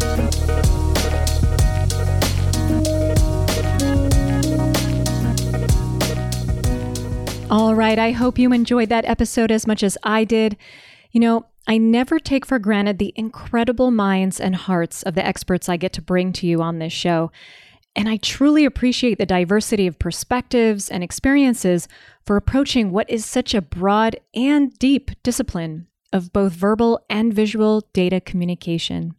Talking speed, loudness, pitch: 130 wpm, -19 LUFS, 195 Hz